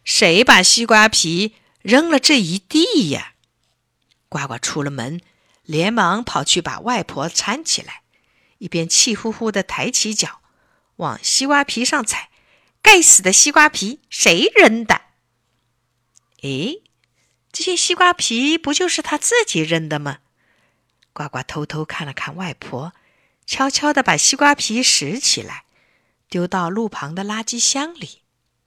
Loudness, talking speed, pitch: -15 LUFS, 195 characters per minute, 225 Hz